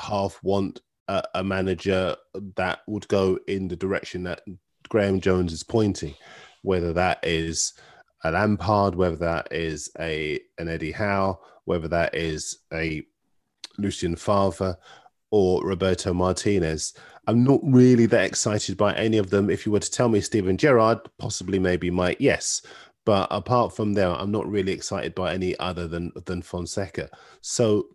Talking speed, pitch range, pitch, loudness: 155 wpm, 85-105 Hz, 95 Hz, -24 LUFS